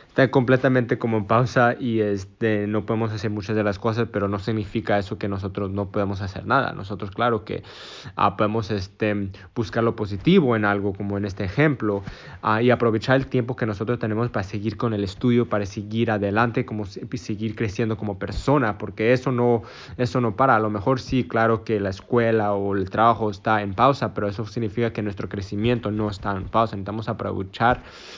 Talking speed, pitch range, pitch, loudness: 200 wpm, 100-120 Hz, 110 Hz, -23 LUFS